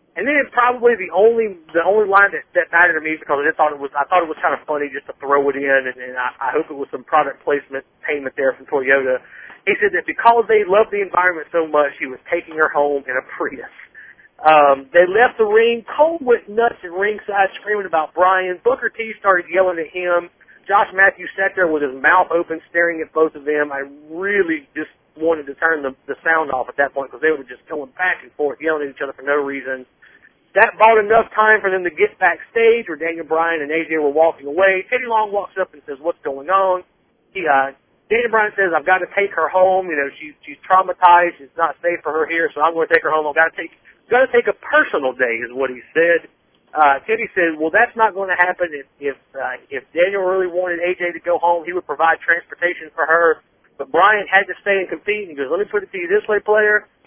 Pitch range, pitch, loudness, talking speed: 150-200 Hz, 170 Hz, -17 LUFS, 250 wpm